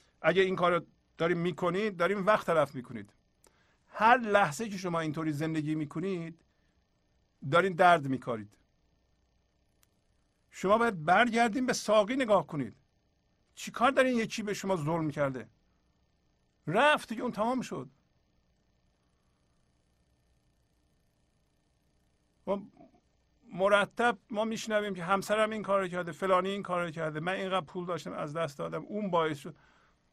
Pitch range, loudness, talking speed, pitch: 130-210 Hz, -30 LUFS, 125 wpm, 175 Hz